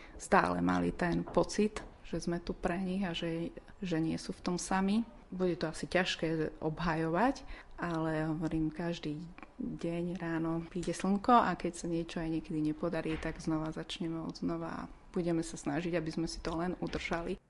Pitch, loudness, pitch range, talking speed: 170 Hz, -35 LUFS, 160-180 Hz, 175 wpm